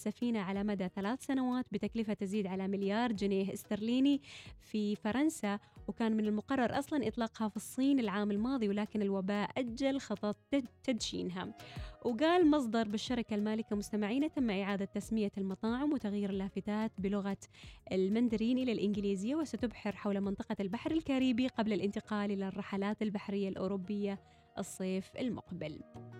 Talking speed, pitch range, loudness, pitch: 125 wpm, 200-240 Hz, -35 LUFS, 210 Hz